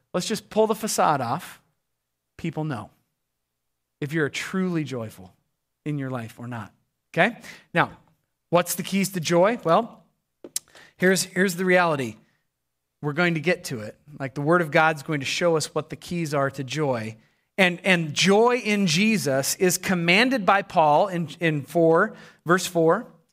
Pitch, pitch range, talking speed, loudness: 165 Hz, 135-185 Hz, 165 wpm, -23 LUFS